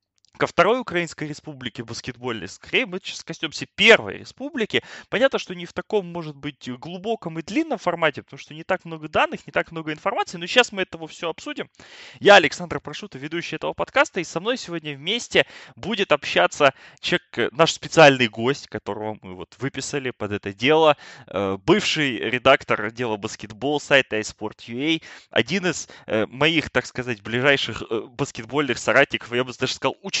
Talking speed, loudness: 160 wpm, -22 LUFS